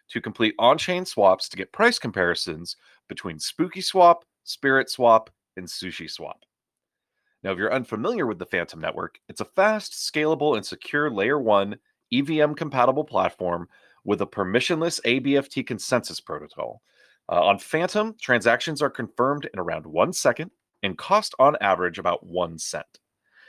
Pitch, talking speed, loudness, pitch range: 135 Hz, 150 wpm, -23 LUFS, 110-165 Hz